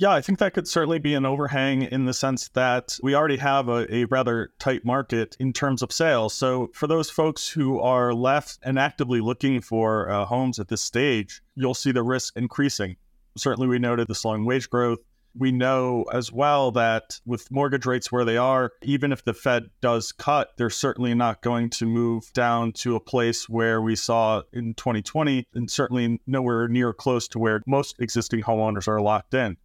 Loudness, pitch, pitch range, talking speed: -24 LUFS, 125 Hz, 115-135 Hz, 200 wpm